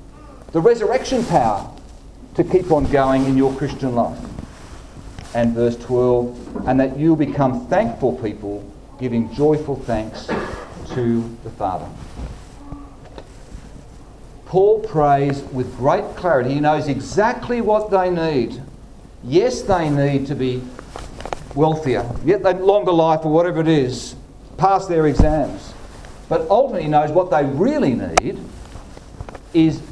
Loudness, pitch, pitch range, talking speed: -18 LUFS, 140 Hz, 125-165 Hz, 125 wpm